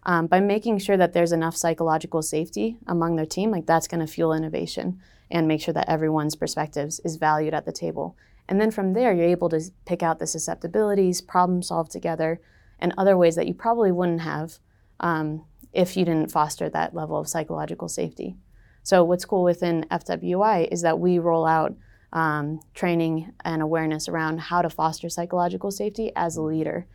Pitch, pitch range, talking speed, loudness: 165 Hz, 155-180 Hz, 185 wpm, -24 LUFS